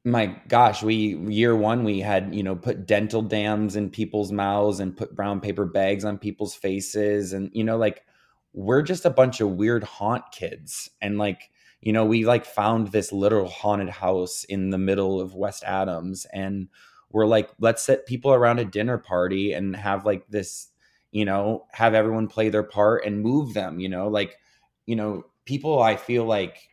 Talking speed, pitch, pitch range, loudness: 190 wpm, 105 Hz, 100-110 Hz, -24 LUFS